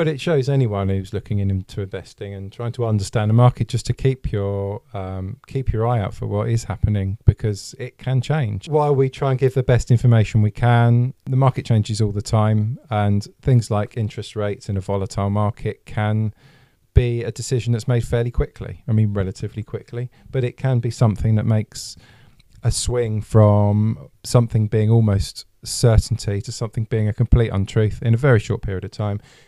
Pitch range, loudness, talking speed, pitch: 105-125 Hz, -20 LUFS, 195 wpm, 115 Hz